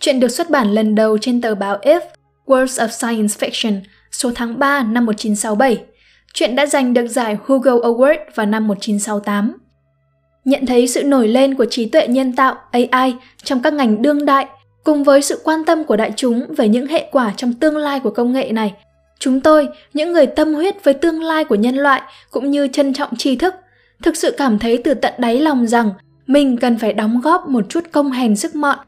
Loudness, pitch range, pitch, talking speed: -15 LUFS, 225-290 Hz, 260 Hz, 210 wpm